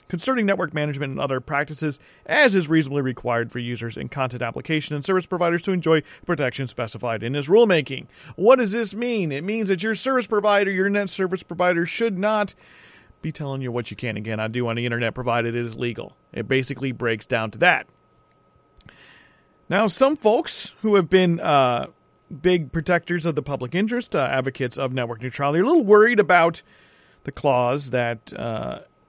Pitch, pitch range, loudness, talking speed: 155 Hz, 125-195 Hz, -22 LUFS, 185 wpm